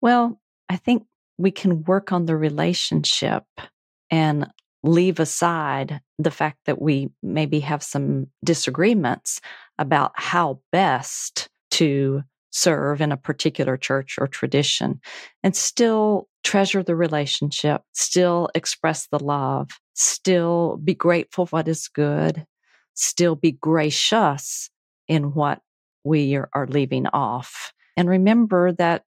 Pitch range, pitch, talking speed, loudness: 145-180 Hz, 160 Hz, 120 wpm, -21 LUFS